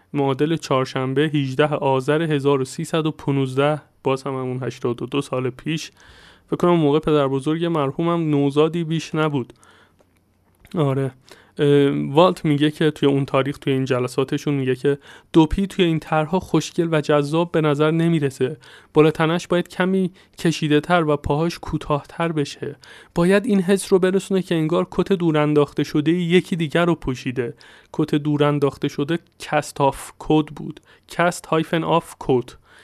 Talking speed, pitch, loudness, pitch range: 140 wpm, 150 Hz, -20 LUFS, 140-165 Hz